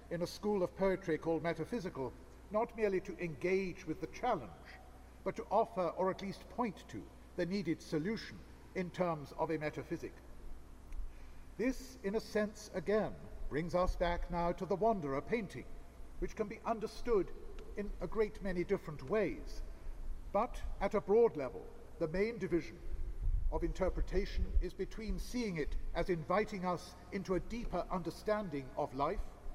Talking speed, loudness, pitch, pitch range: 155 wpm, -38 LUFS, 180 Hz, 160-205 Hz